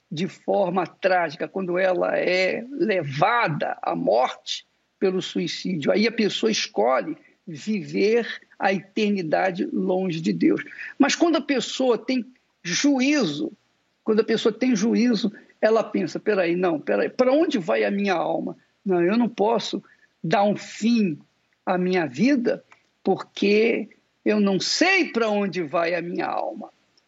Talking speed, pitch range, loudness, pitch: 140 wpm, 185-245 Hz, -23 LUFS, 210 Hz